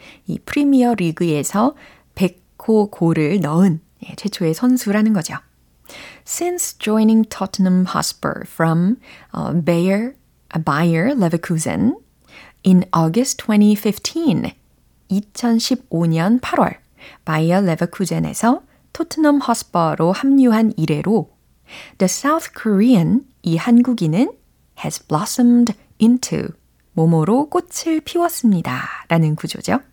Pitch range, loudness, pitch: 170-245 Hz, -17 LUFS, 210 Hz